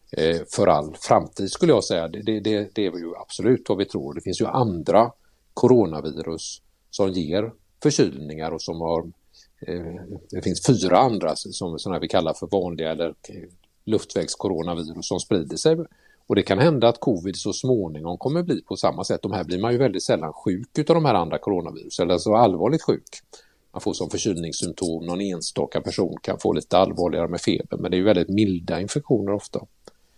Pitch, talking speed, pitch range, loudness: 90 Hz, 185 wpm, 85-110 Hz, -23 LUFS